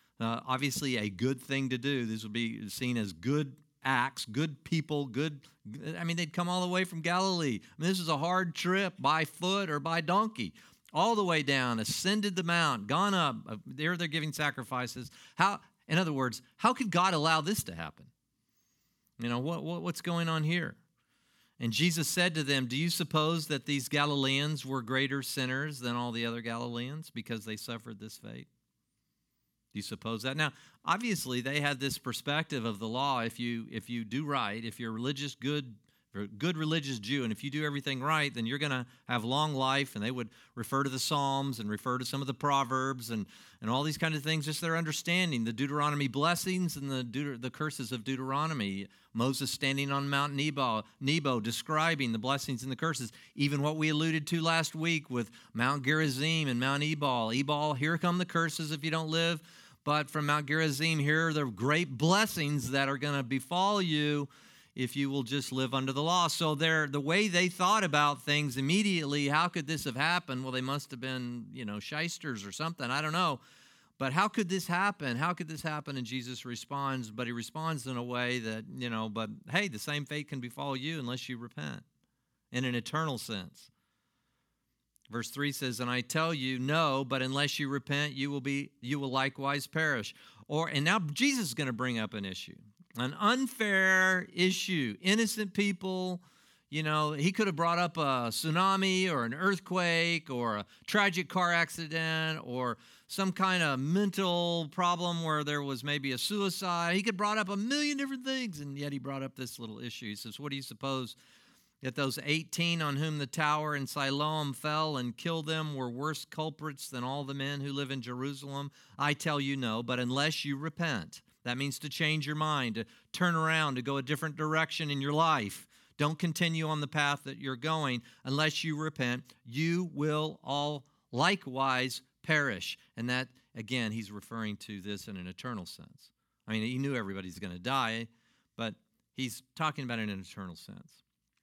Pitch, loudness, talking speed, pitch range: 145 Hz, -32 LUFS, 200 wpm, 125-160 Hz